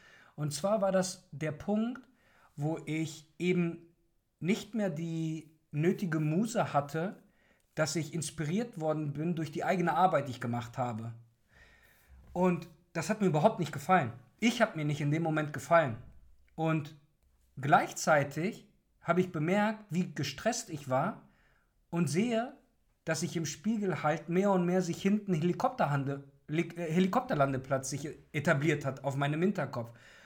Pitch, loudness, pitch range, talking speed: 165 Hz, -32 LUFS, 145-185 Hz, 145 wpm